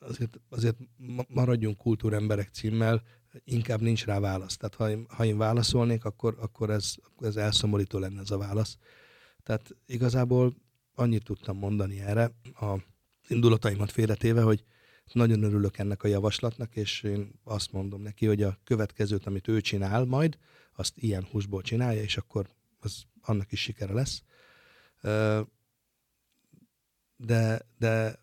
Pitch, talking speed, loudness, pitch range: 110 Hz, 135 wpm, -29 LUFS, 105-115 Hz